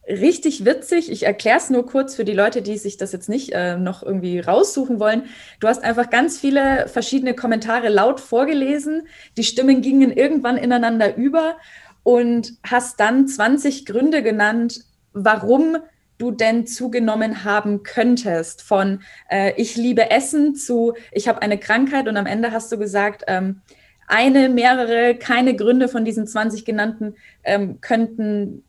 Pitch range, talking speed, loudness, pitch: 210-260 Hz, 155 wpm, -18 LUFS, 235 Hz